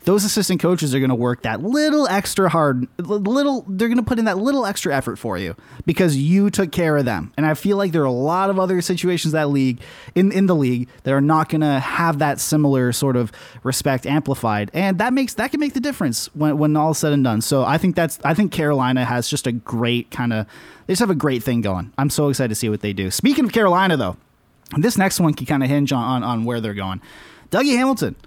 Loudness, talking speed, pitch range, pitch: -19 LUFS, 250 wpm, 125-190 Hz, 150 Hz